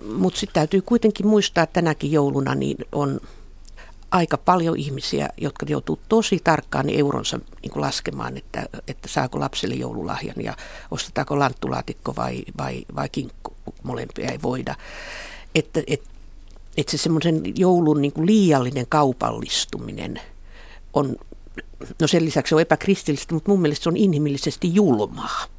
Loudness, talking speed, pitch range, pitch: -22 LUFS, 135 wpm, 140-180 Hz, 155 Hz